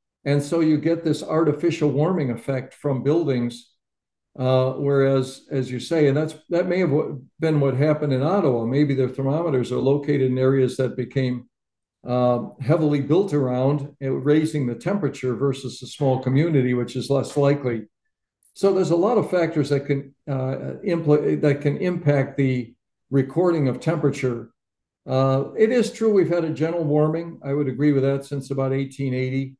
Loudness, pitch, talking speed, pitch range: -22 LUFS, 140 Hz, 170 wpm, 130-155 Hz